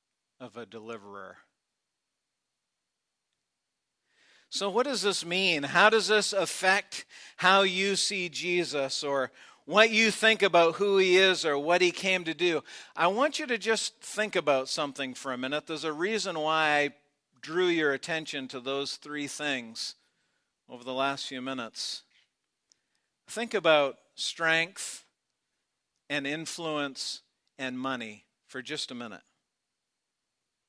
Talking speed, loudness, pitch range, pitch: 135 wpm, -27 LUFS, 135-195 Hz, 160 Hz